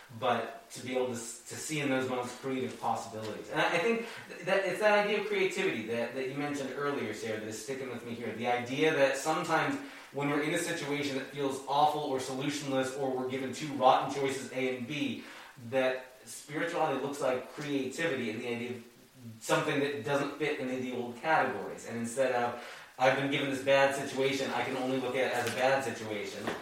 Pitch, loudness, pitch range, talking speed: 135 Hz, -32 LUFS, 120-145 Hz, 210 wpm